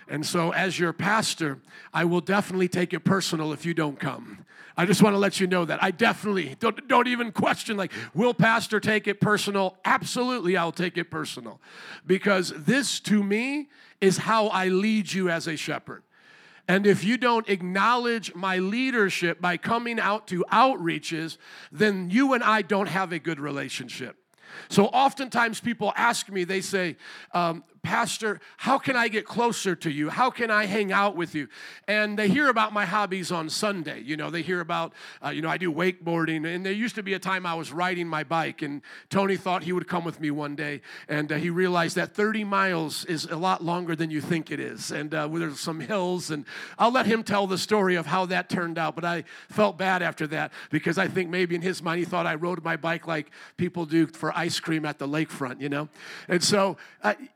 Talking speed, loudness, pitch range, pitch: 215 wpm, -25 LUFS, 165-210 Hz, 185 Hz